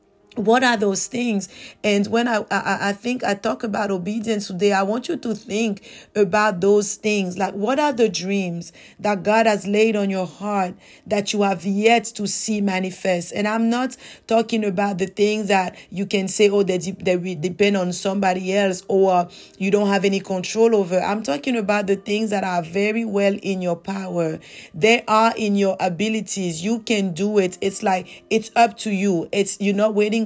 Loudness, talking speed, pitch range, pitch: -20 LUFS, 195 wpm, 195-220 Hz, 205 Hz